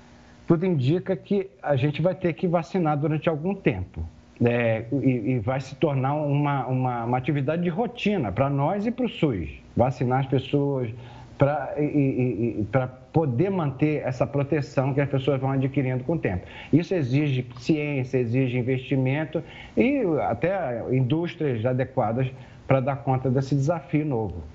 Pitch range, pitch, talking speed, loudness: 130-155 Hz, 140 Hz, 145 wpm, -25 LUFS